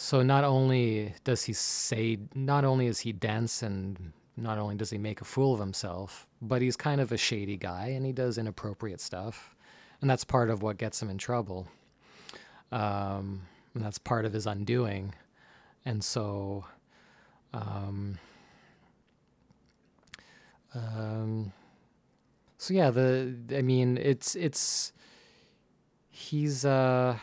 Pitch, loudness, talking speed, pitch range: 115 Hz, -31 LUFS, 135 wpm, 100-130 Hz